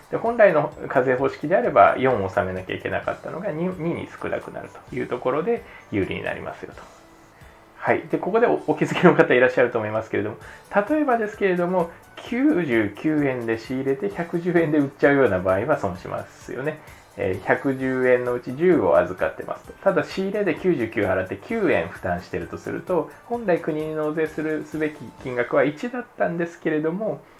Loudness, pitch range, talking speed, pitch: -23 LUFS, 130-190 Hz, 360 characters per minute, 155 Hz